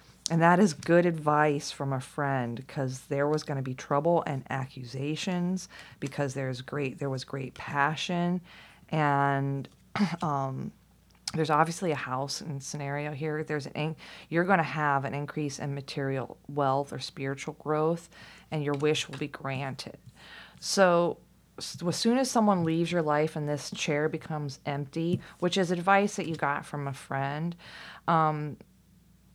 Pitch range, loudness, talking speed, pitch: 140-165 Hz, -29 LUFS, 160 wpm, 150 Hz